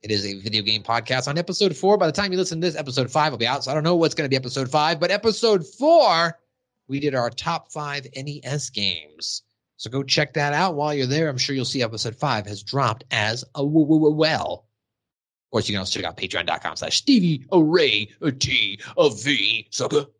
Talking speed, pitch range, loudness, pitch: 215 wpm, 125-170 Hz, -21 LUFS, 145 Hz